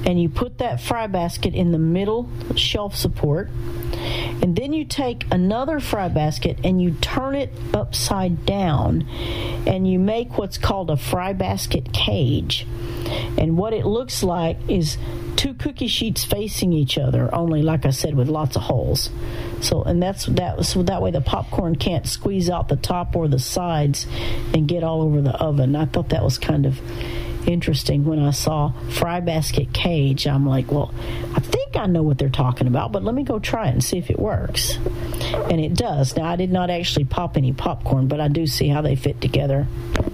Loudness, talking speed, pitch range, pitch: -21 LUFS, 195 wpm, 120-170 Hz, 145 Hz